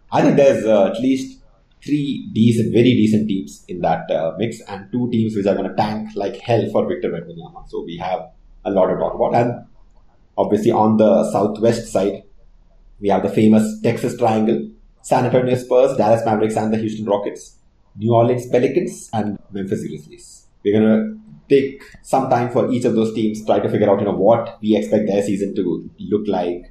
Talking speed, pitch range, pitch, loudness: 200 wpm, 100-115 Hz, 110 Hz, -18 LUFS